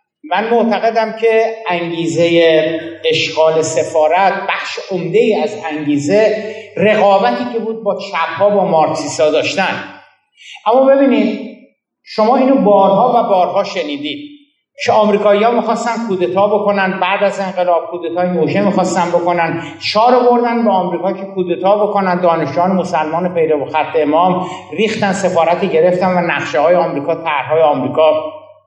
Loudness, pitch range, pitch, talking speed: -13 LUFS, 165-215 Hz, 190 Hz, 120 wpm